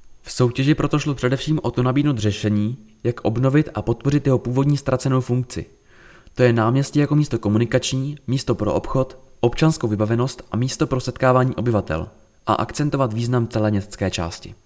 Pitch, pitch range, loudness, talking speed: 125 Hz, 110-135 Hz, -21 LUFS, 160 wpm